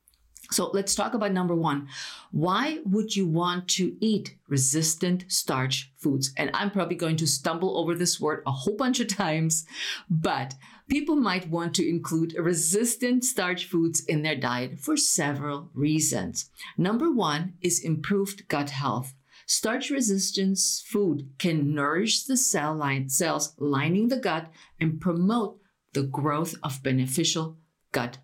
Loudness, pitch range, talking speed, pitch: -26 LUFS, 150-200 Hz, 140 wpm, 170 Hz